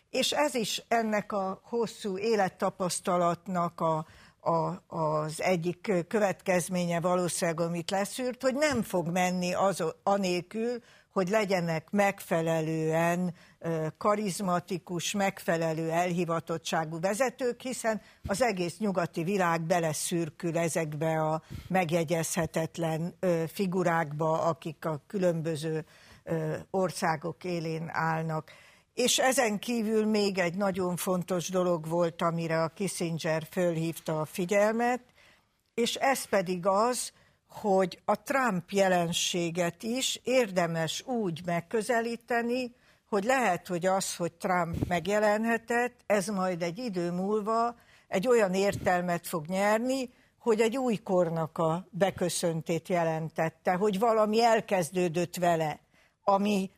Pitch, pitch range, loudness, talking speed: 180 Hz, 170-210 Hz, -29 LUFS, 105 wpm